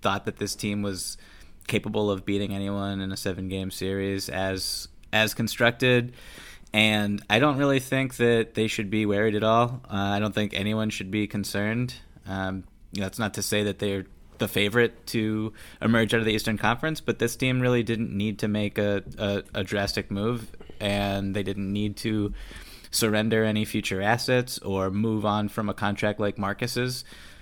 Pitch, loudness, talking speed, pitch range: 105 Hz, -26 LUFS, 185 wpm, 100-110 Hz